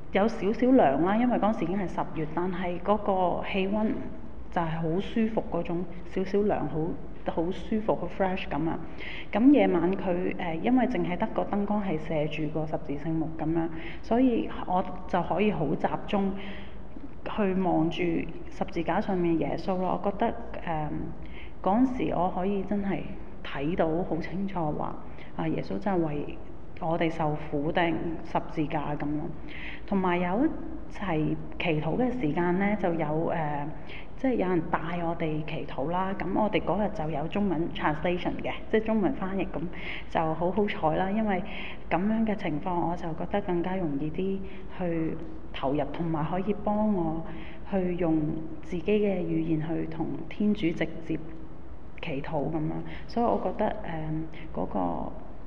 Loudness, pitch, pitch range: -29 LUFS, 175 Hz, 160-200 Hz